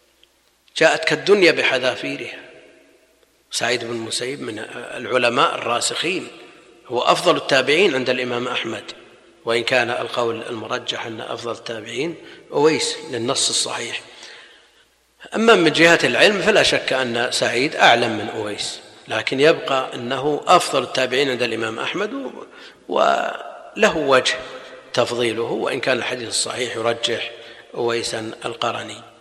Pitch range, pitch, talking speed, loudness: 115-150 Hz, 125 Hz, 110 wpm, -19 LUFS